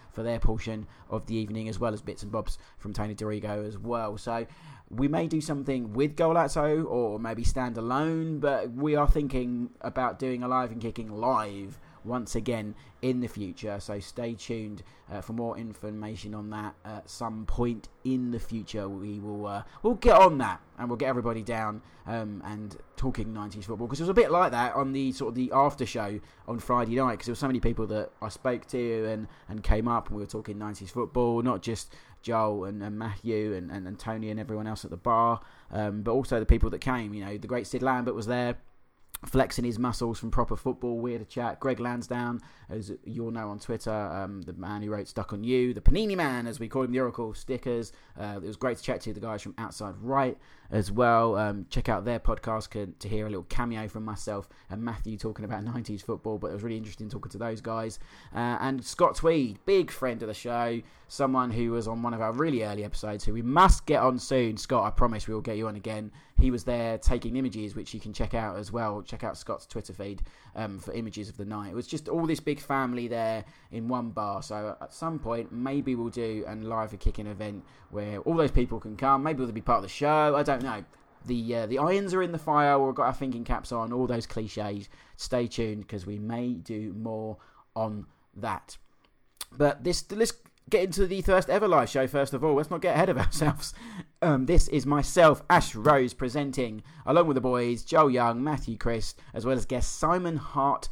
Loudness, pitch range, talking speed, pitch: -29 LUFS, 105-130 Hz, 225 wpm, 115 Hz